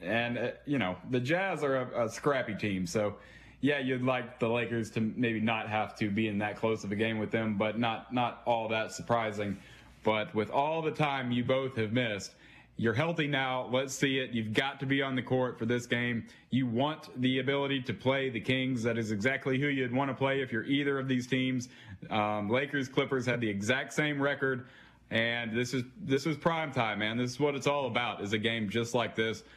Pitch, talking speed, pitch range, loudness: 125 Hz, 225 wpm, 110-135 Hz, -31 LUFS